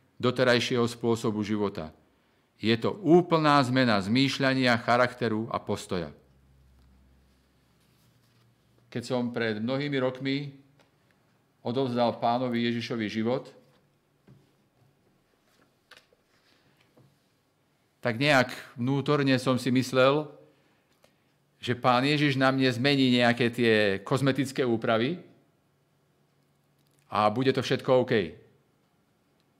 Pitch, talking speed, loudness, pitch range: 125 Hz, 85 wpm, -26 LUFS, 110-135 Hz